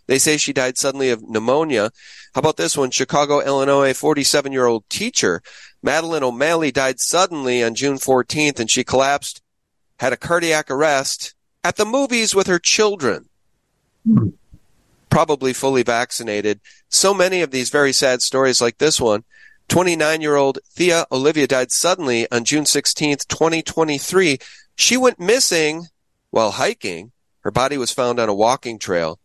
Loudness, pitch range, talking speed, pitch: -17 LUFS, 125-165 Hz, 150 wpm, 140 Hz